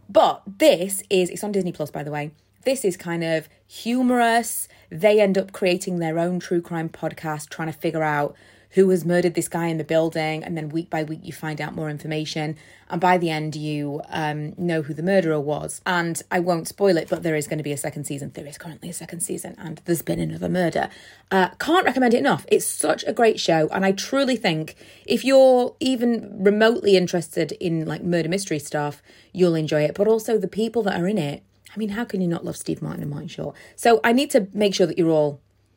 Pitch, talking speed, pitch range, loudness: 175 Hz, 230 wpm, 155-200 Hz, -22 LUFS